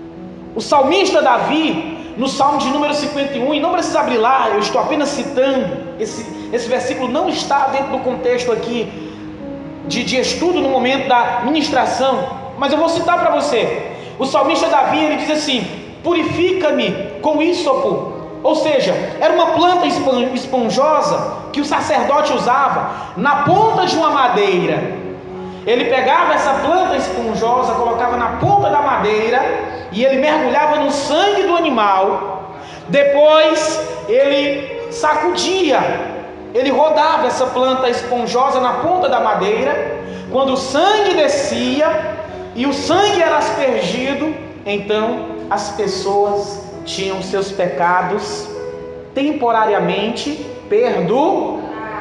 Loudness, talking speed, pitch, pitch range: -16 LUFS, 125 wpm, 275 Hz, 235-310 Hz